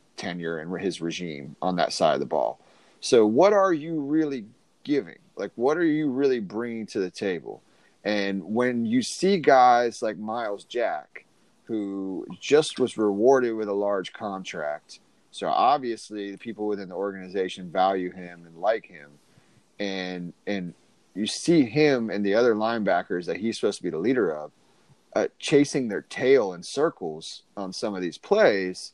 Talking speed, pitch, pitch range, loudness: 170 wpm, 105 Hz, 95-120 Hz, -25 LUFS